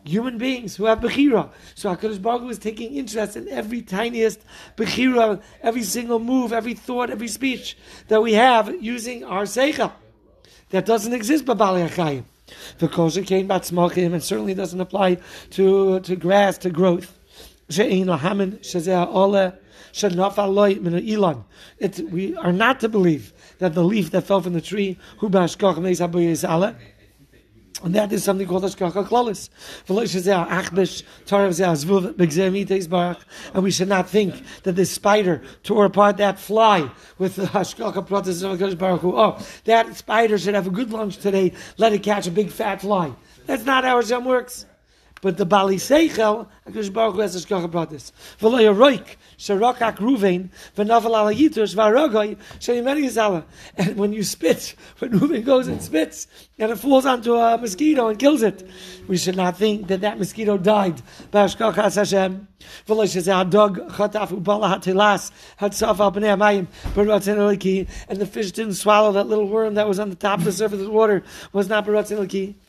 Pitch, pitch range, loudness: 200 Hz, 185-220 Hz, -20 LUFS